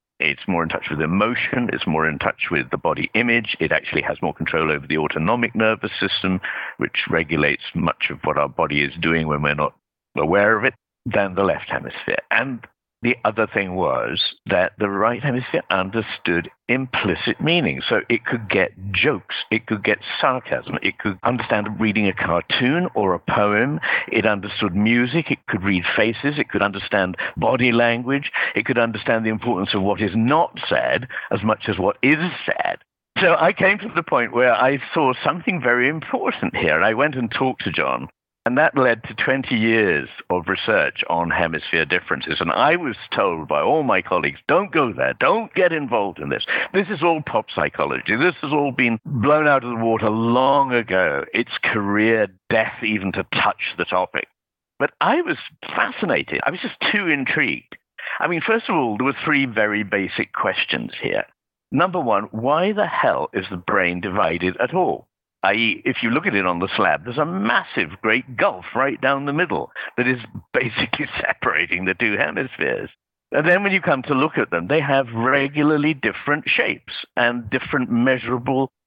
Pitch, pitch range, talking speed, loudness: 115 Hz, 100-135 Hz, 185 wpm, -20 LUFS